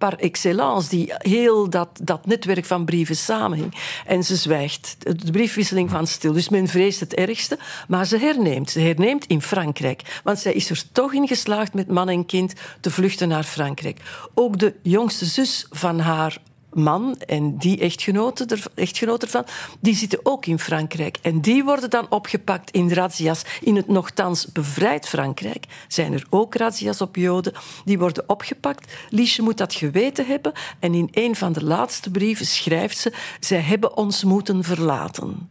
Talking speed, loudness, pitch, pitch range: 170 wpm, -21 LUFS, 185 Hz, 165-210 Hz